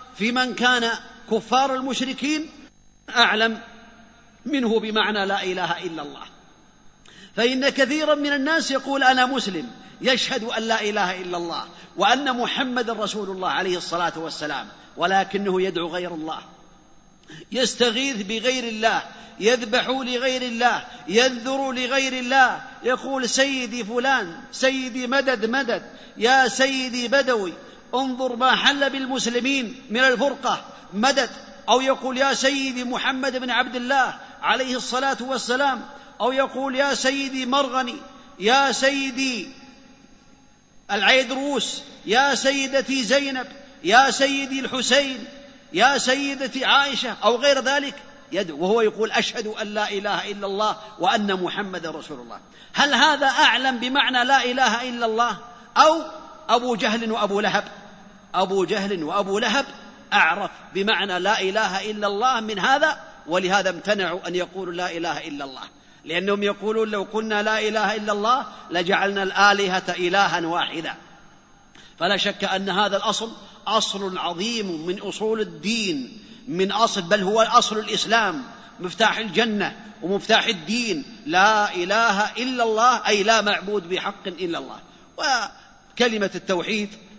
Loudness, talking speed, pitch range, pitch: -21 LUFS, 125 wpm, 205-265 Hz, 240 Hz